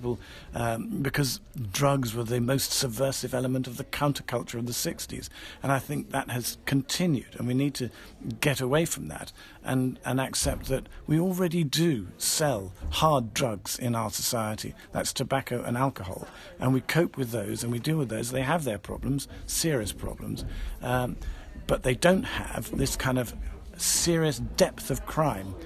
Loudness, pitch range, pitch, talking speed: -28 LUFS, 115-140 Hz, 125 Hz, 170 wpm